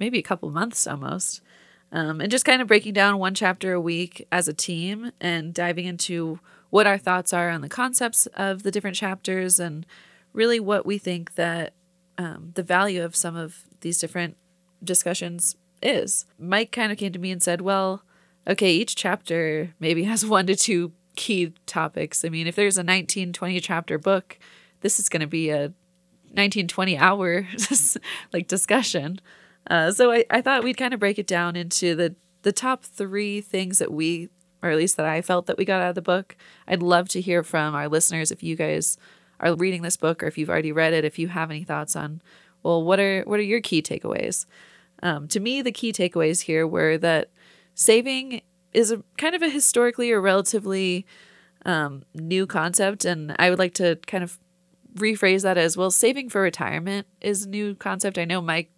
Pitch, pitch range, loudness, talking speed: 180 Hz, 170-200 Hz, -23 LUFS, 200 wpm